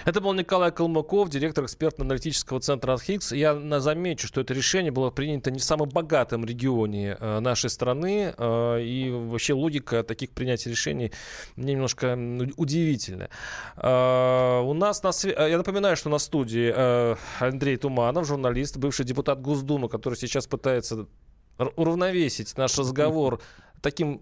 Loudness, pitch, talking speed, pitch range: -26 LUFS, 135 Hz, 130 wpm, 125-155 Hz